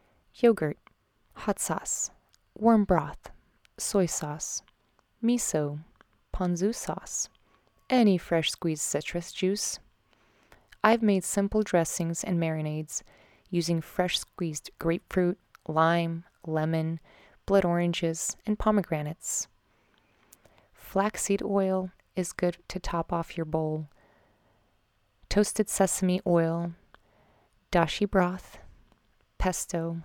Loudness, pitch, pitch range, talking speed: -28 LUFS, 175 Hz, 160-195 Hz, 90 wpm